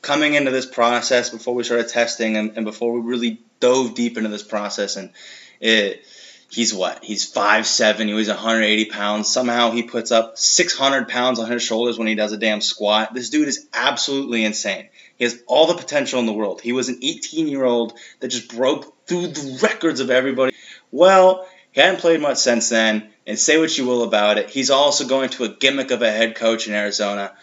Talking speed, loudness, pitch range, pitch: 210 wpm, -18 LUFS, 110-135 Hz, 120 Hz